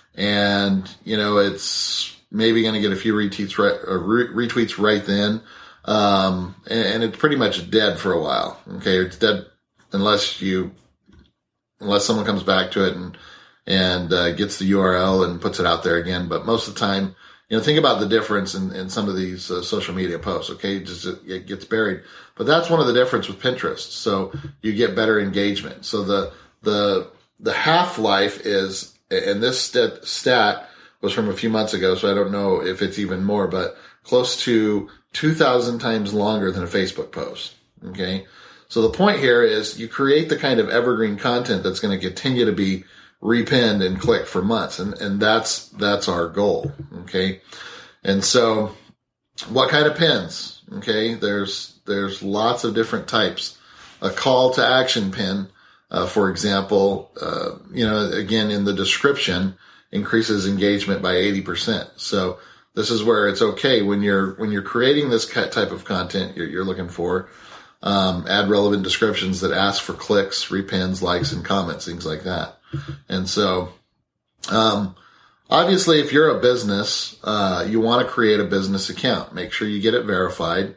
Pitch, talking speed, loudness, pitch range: 100 Hz, 180 wpm, -20 LUFS, 95-115 Hz